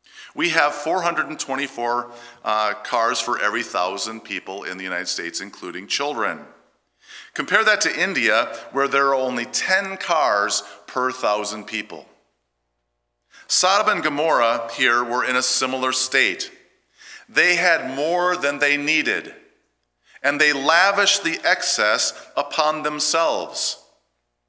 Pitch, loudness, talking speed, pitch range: 125 Hz, -20 LUFS, 125 wpm, 105-140 Hz